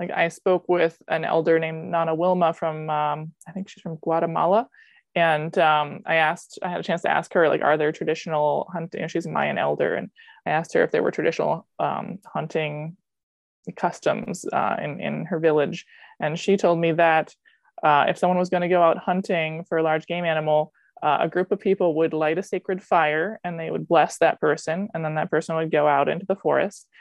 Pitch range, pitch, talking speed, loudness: 155-180 Hz, 165 Hz, 220 wpm, -23 LUFS